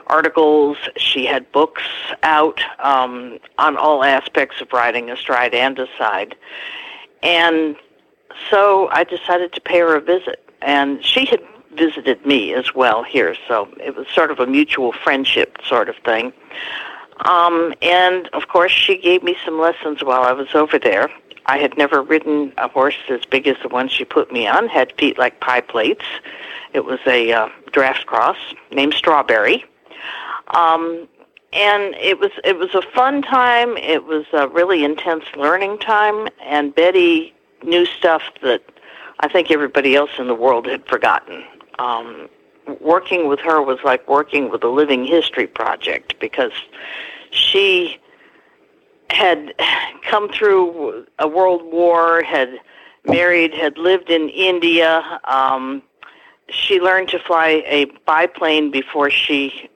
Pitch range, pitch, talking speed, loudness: 145-200 Hz, 170 Hz, 150 wpm, -16 LUFS